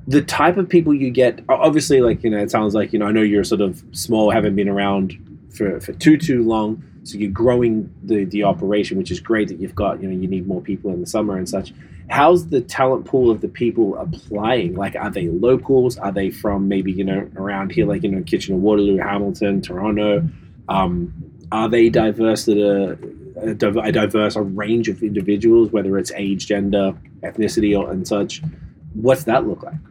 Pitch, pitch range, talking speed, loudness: 105 Hz, 100-115 Hz, 205 wpm, -18 LUFS